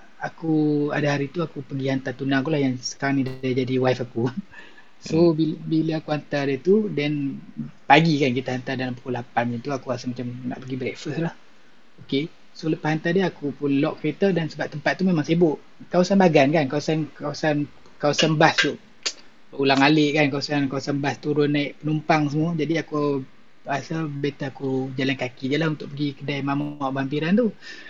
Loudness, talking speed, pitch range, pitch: -23 LUFS, 195 wpm, 135-160 Hz, 145 Hz